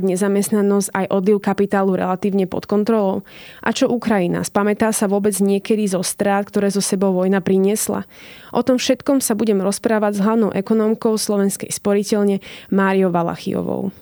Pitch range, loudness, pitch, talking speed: 195-220 Hz, -18 LUFS, 200 Hz, 145 wpm